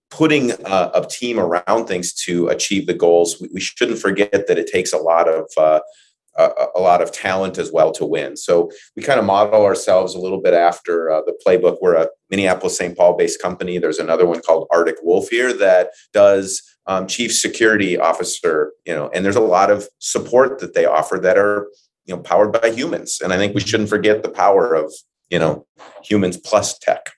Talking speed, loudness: 210 wpm, -17 LUFS